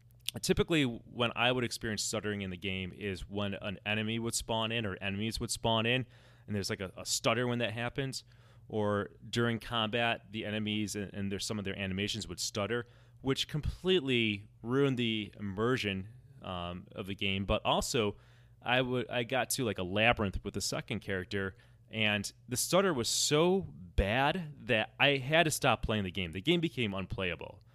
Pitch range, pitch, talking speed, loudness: 100-120 Hz, 115 Hz, 185 wpm, -33 LUFS